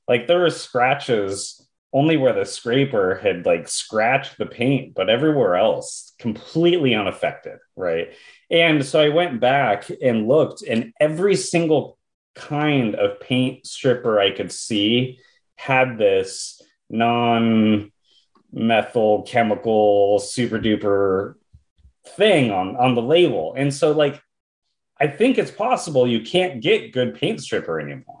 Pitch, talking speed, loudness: 140 Hz, 130 wpm, -19 LUFS